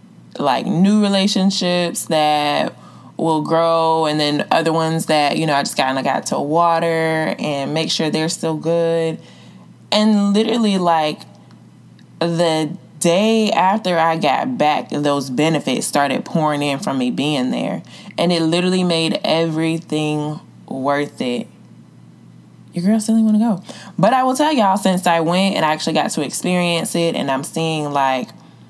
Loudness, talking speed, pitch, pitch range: -17 LUFS, 160 wpm, 165 Hz, 150-185 Hz